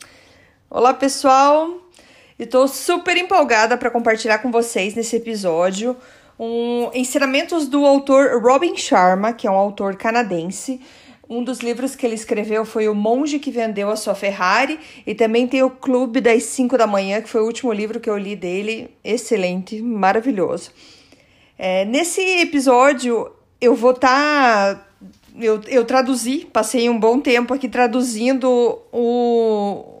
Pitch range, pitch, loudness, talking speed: 220-265 Hz, 240 Hz, -17 LUFS, 145 wpm